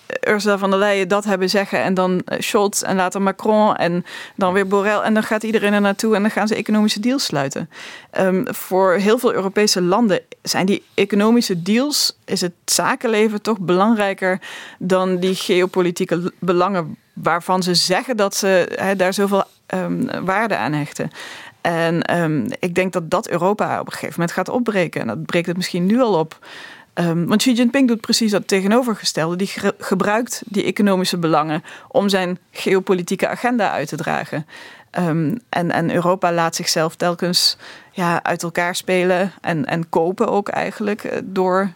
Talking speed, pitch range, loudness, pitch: 175 wpm, 180-210 Hz, -18 LUFS, 190 Hz